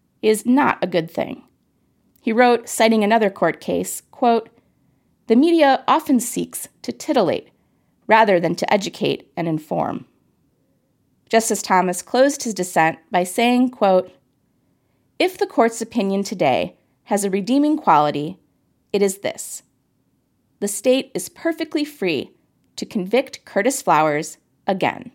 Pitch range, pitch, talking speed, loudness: 185-255 Hz, 225 Hz, 130 wpm, -19 LUFS